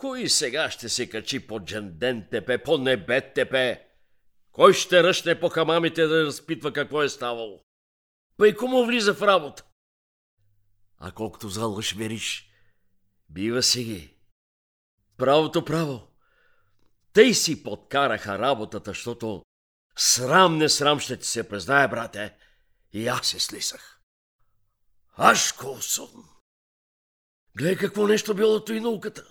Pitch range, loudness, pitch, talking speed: 100-160 Hz, -23 LUFS, 115 Hz, 120 wpm